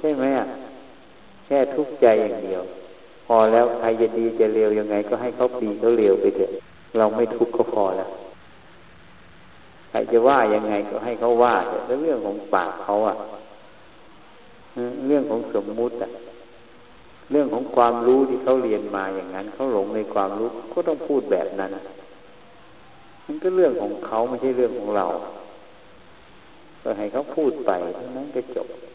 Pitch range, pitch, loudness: 105-130 Hz, 120 Hz, -22 LUFS